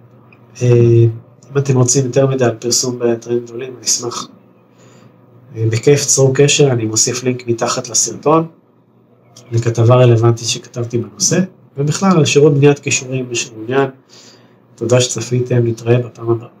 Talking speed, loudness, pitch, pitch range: 125 wpm, -14 LUFS, 125 Hz, 115-135 Hz